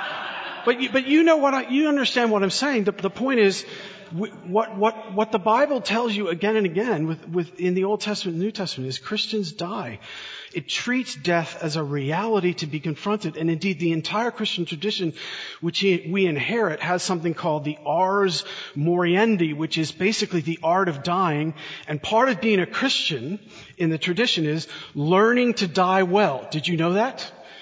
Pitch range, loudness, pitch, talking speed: 165-220 Hz, -23 LUFS, 190 Hz, 190 wpm